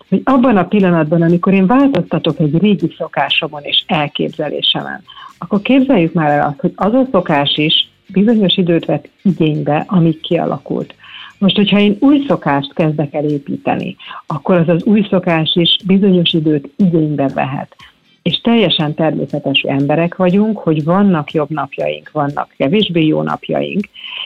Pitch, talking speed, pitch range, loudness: 170 Hz, 145 wpm, 155-200 Hz, -14 LUFS